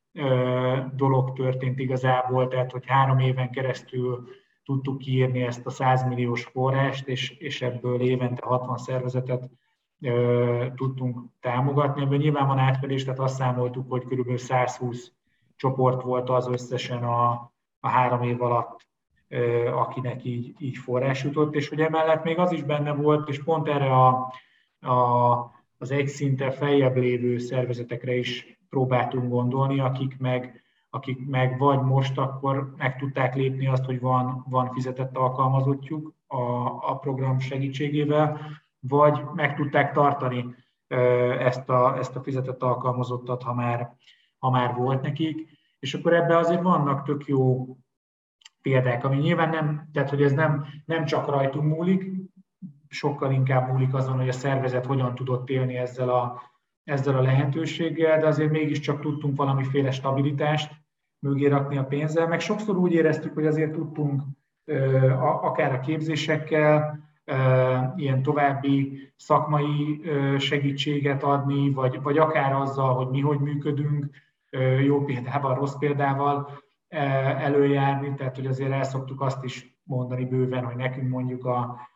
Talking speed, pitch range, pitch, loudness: 140 wpm, 125-145 Hz, 135 Hz, -25 LUFS